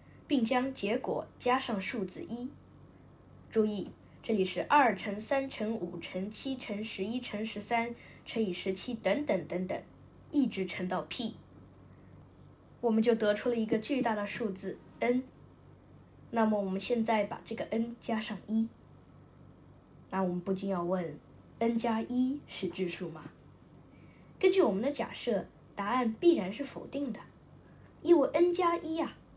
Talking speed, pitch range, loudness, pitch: 210 characters per minute, 195-250 Hz, -33 LUFS, 225 Hz